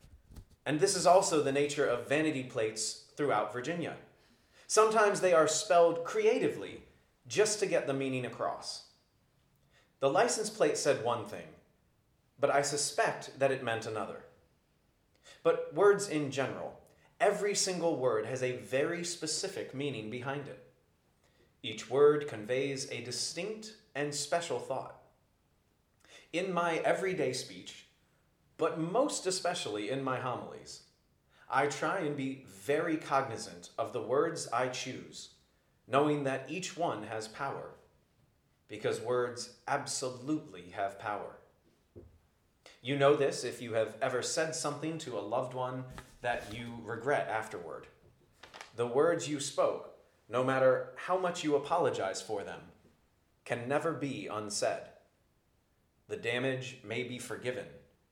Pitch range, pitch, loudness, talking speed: 120-170 Hz, 140 Hz, -33 LUFS, 130 wpm